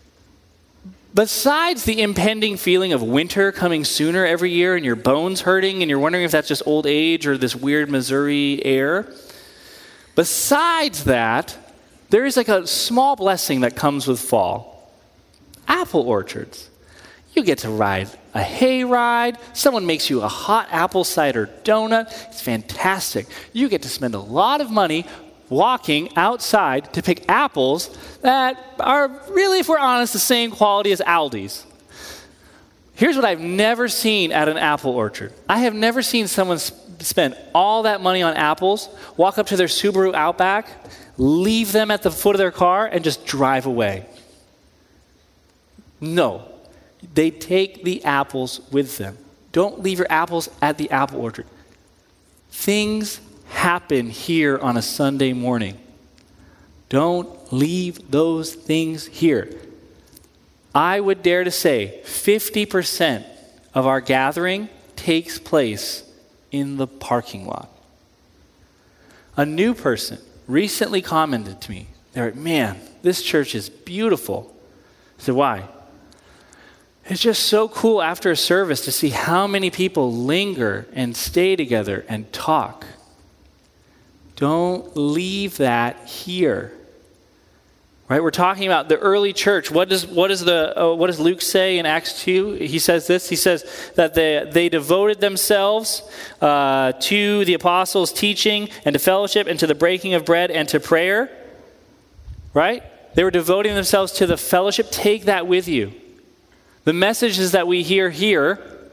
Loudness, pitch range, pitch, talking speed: -19 LUFS, 135-200 Hz, 170 Hz, 145 wpm